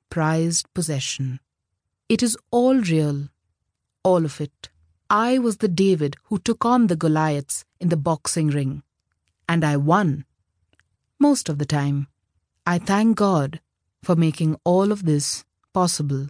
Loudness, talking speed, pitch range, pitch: -21 LUFS, 140 wpm, 135-180 Hz, 155 Hz